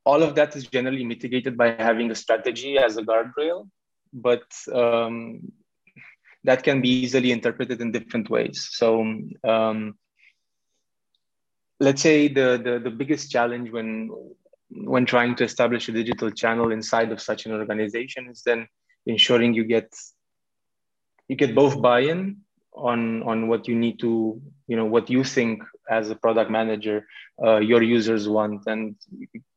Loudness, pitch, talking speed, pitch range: -23 LUFS, 120 Hz, 150 wpm, 115-130 Hz